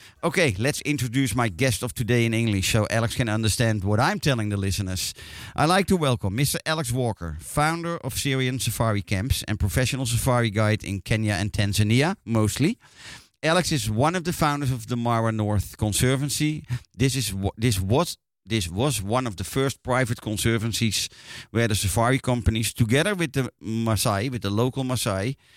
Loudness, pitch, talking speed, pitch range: -24 LUFS, 120 Hz, 175 wpm, 105-135 Hz